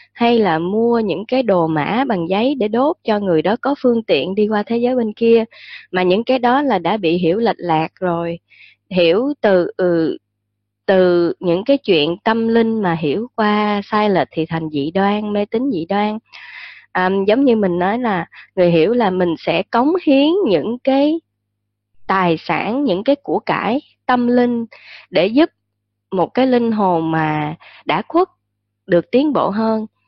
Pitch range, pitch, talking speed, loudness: 170-240 Hz, 205 Hz, 185 wpm, -17 LUFS